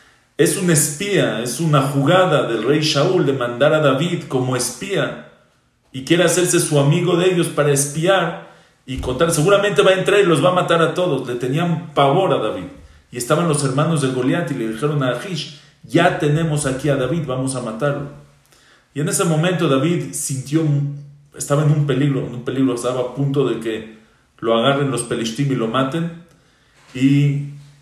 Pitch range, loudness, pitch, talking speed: 130-165 Hz, -18 LUFS, 145 Hz, 190 wpm